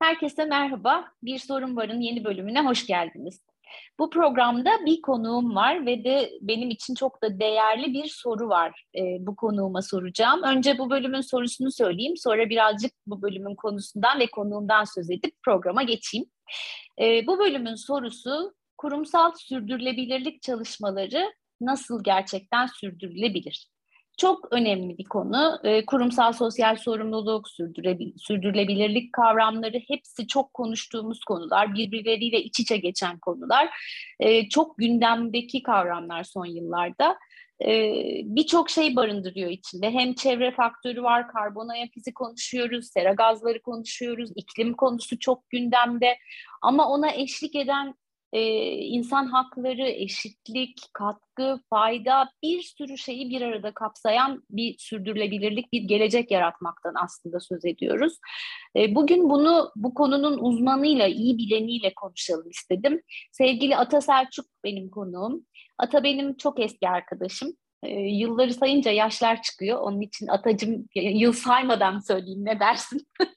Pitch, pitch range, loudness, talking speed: 235 Hz, 210-270 Hz, -25 LUFS, 125 wpm